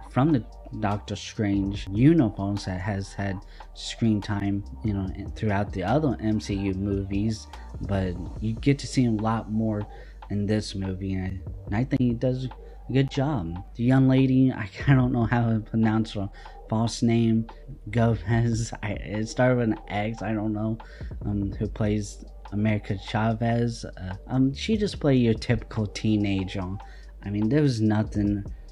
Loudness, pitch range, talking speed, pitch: -26 LUFS, 100-120 Hz, 175 wpm, 110 Hz